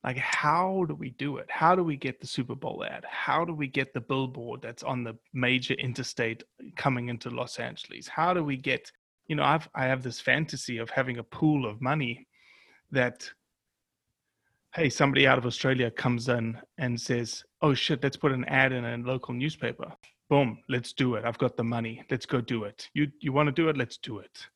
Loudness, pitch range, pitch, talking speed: -29 LUFS, 120-140 Hz, 130 Hz, 215 wpm